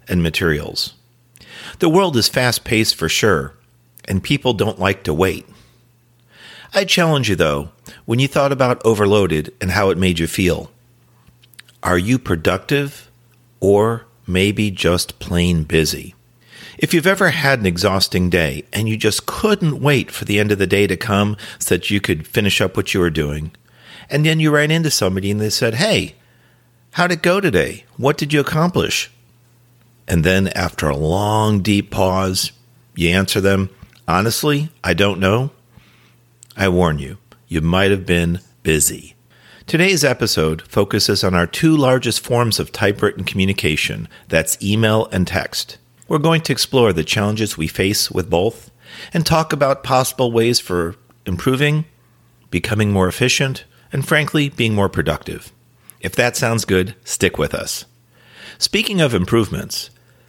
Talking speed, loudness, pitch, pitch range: 155 wpm, -17 LUFS, 110 Hz, 95-125 Hz